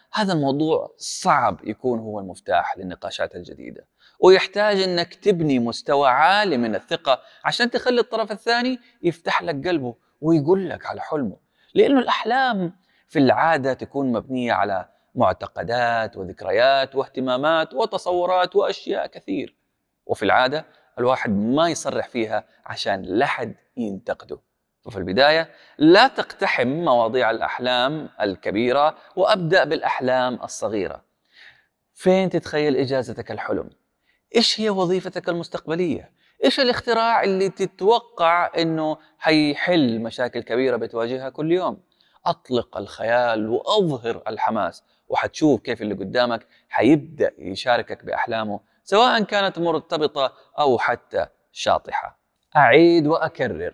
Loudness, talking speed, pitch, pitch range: -21 LUFS, 105 wpm, 165 Hz, 130-200 Hz